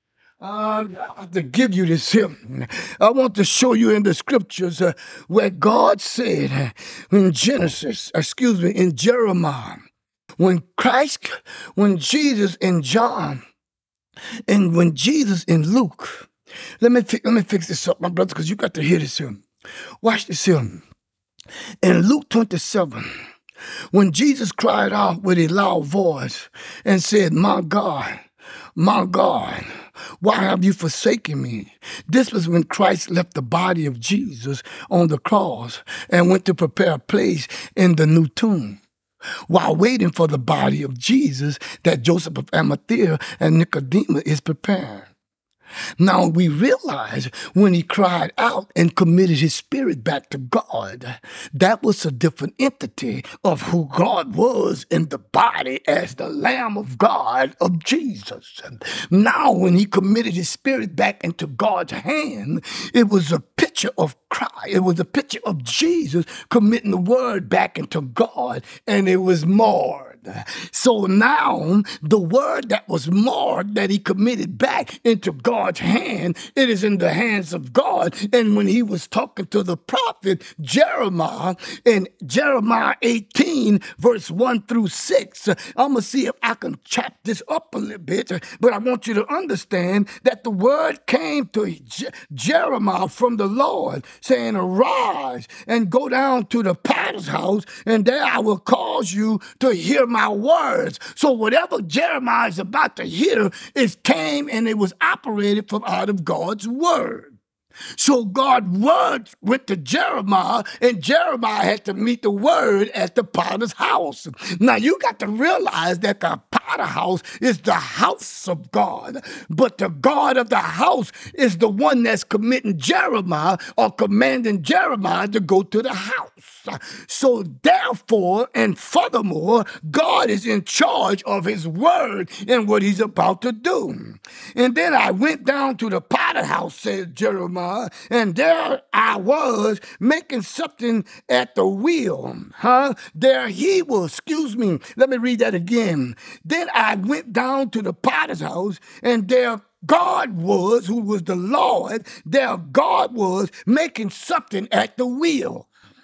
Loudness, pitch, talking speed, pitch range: -19 LUFS, 210 Hz, 155 wpm, 180-250 Hz